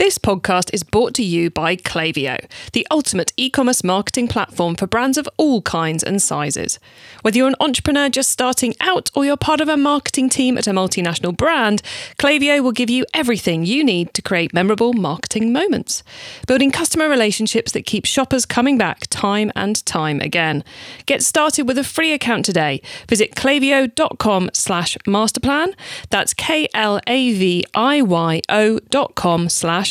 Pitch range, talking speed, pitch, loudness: 185-275 Hz, 155 wpm, 230 Hz, -17 LUFS